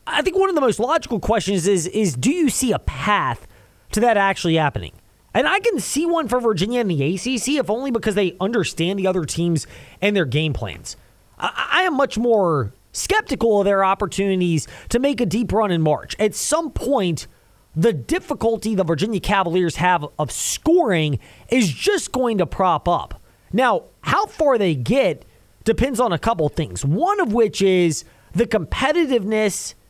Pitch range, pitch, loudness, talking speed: 170-245 Hz, 205 Hz, -20 LUFS, 180 wpm